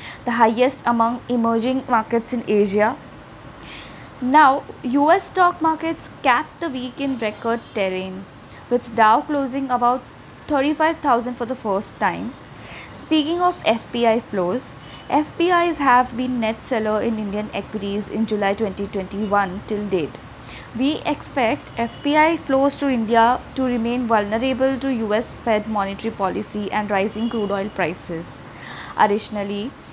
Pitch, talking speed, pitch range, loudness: 230 Hz, 125 wpm, 205-265 Hz, -20 LUFS